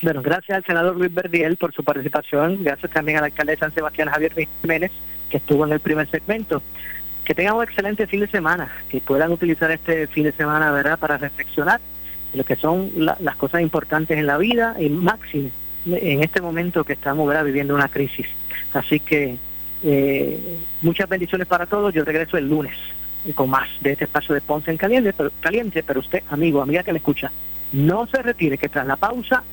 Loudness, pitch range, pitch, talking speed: -20 LUFS, 140-175 Hz, 155 Hz, 200 wpm